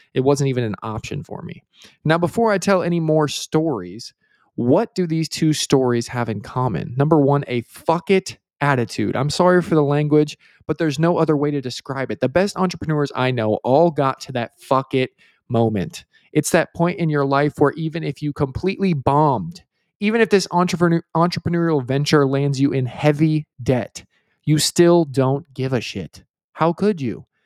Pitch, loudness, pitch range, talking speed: 145 Hz, -19 LUFS, 130-170 Hz, 185 wpm